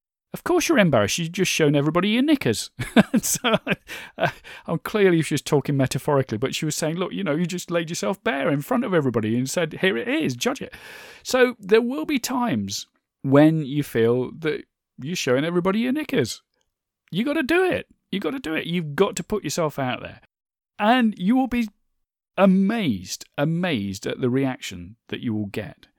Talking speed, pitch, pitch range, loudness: 195 wpm, 170 Hz, 140-225 Hz, -22 LUFS